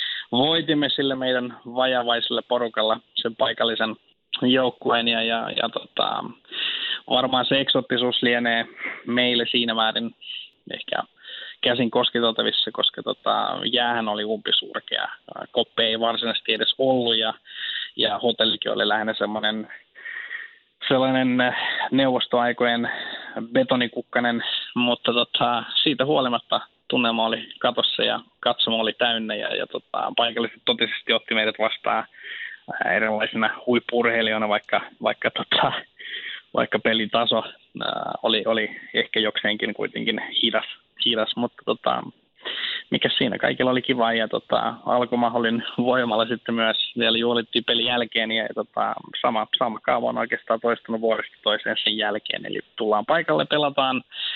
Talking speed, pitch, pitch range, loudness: 120 wpm, 120 Hz, 115-125 Hz, -22 LUFS